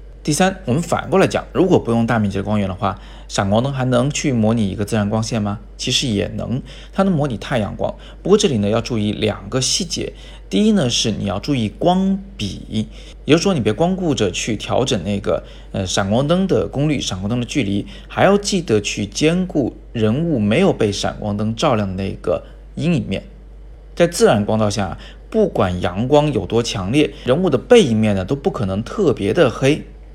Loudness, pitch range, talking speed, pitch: -18 LUFS, 105-150 Hz, 290 characters per minute, 110 Hz